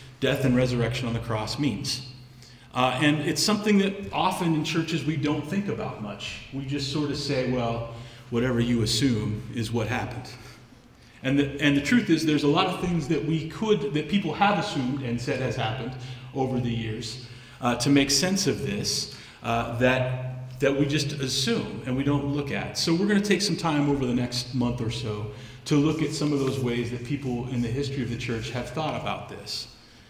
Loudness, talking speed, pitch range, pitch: -26 LUFS, 210 wpm, 120-150 Hz, 130 Hz